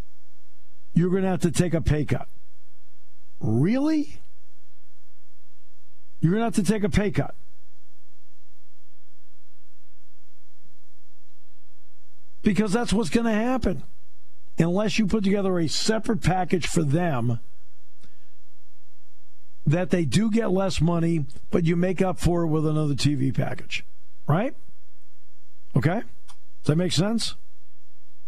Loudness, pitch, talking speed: -24 LUFS, 160 Hz, 120 wpm